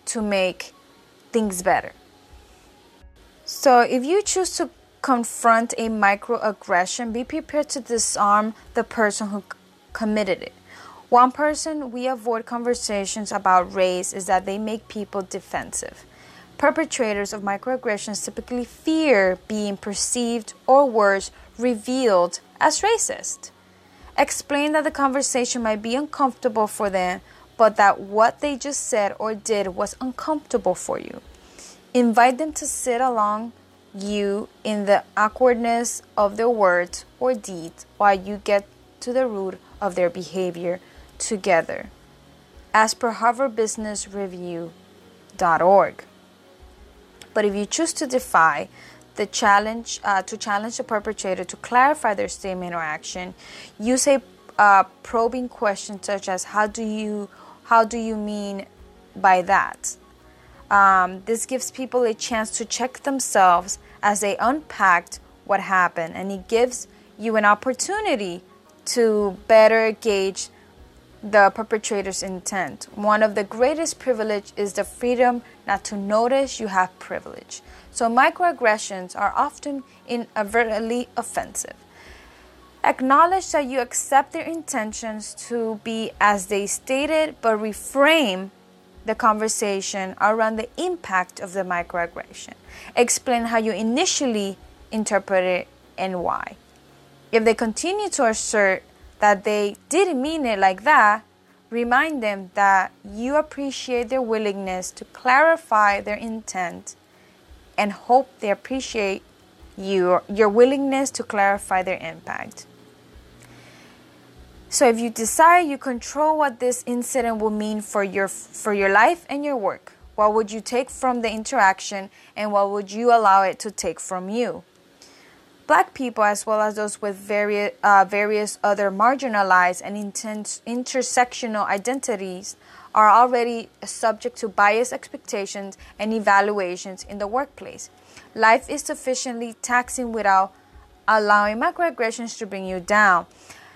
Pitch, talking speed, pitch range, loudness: 220 Hz, 130 wpm, 200-245 Hz, -21 LUFS